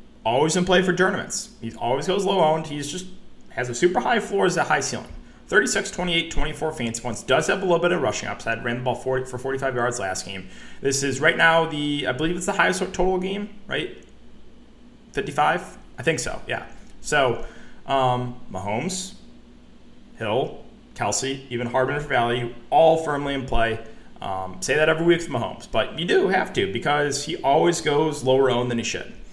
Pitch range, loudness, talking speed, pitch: 125-175 Hz, -23 LUFS, 195 wpm, 145 Hz